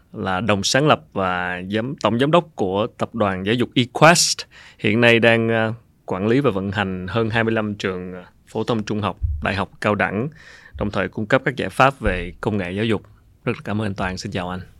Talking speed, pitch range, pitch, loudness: 220 wpm, 95-115 Hz, 105 Hz, -20 LUFS